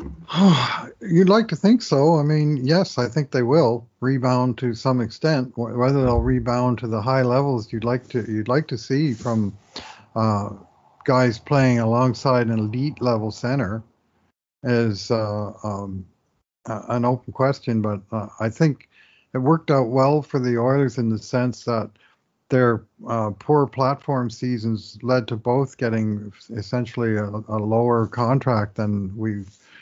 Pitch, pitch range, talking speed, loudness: 120 Hz, 110-130 Hz, 155 wpm, -21 LUFS